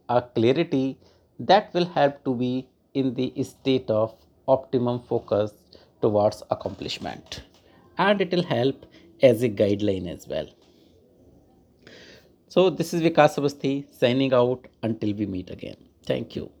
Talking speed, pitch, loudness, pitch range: 130 wpm, 130 Hz, -24 LUFS, 105-140 Hz